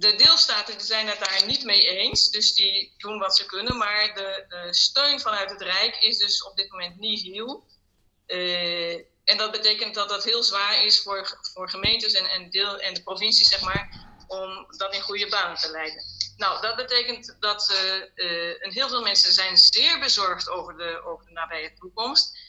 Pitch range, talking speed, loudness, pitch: 180-215 Hz, 195 wpm, -20 LUFS, 195 Hz